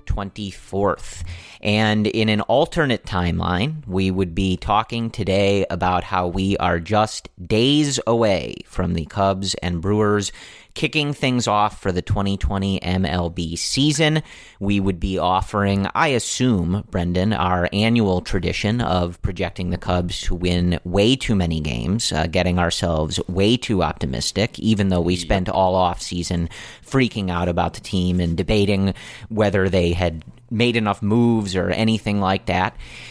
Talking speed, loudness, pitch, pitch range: 145 wpm, -20 LUFS, 95 Hz, 90-110 Hz